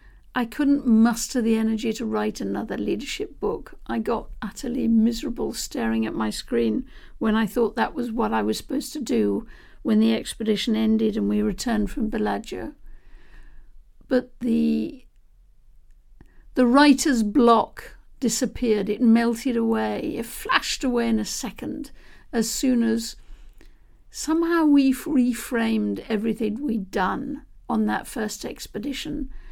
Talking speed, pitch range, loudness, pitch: 135 wpm, 220-260 Hz, -23 LUFS, 235 Hz